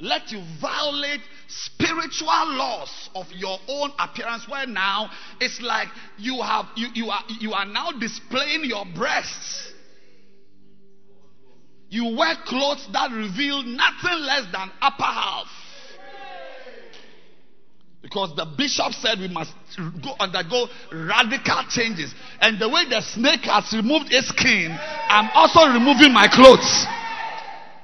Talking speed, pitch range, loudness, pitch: 125 wpm, 195-285 Hz, -19 LUFS, 230 Hz